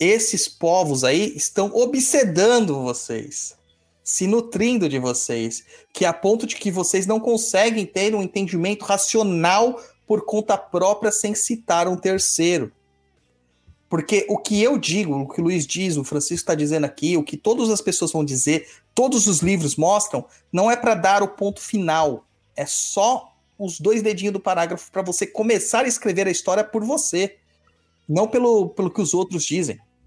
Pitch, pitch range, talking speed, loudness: 195 Hz, 160-215 Hz, 170 wpm, -20 LUFS